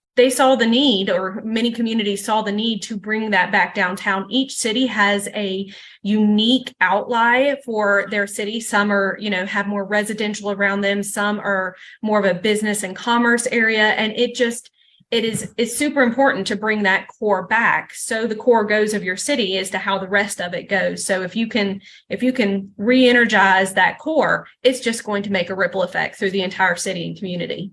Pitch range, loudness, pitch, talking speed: 195-230 Hz, -19 LUFS, 210 Hz, 205 wpm